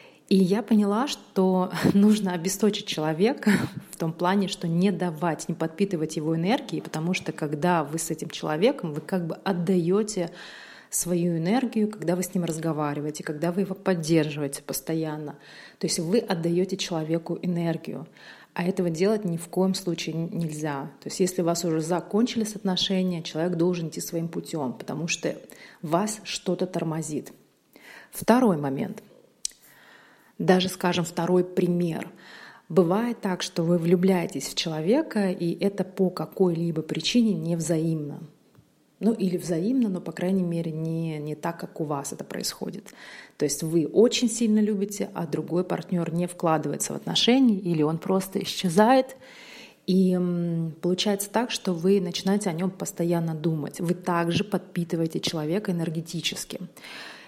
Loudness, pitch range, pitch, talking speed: -26 LUFS, 165-195 Hz, 180 Hz, 145 wpm